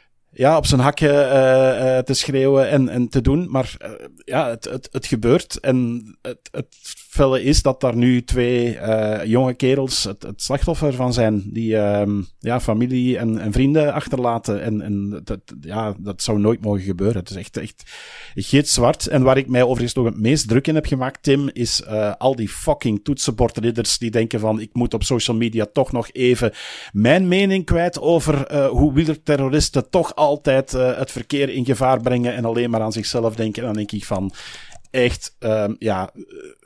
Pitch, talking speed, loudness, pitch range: 125 Hz, 190 wpm, -19 LUFS, 110-135 Hz